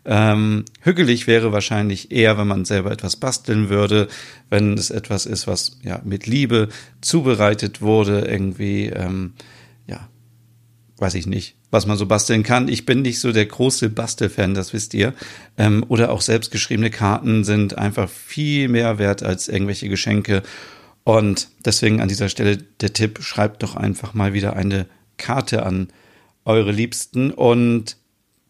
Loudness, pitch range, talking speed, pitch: -19 LUFS, 100-115 Hz, 150 wpm, 110 Hz